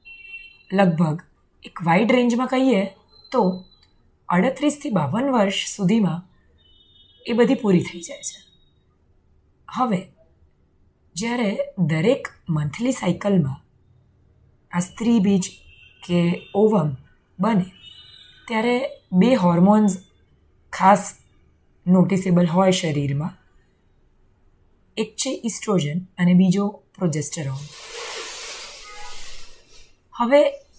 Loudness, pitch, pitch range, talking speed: -21 LUFS, 185 Hz, 135-220 Hz, 80 wpm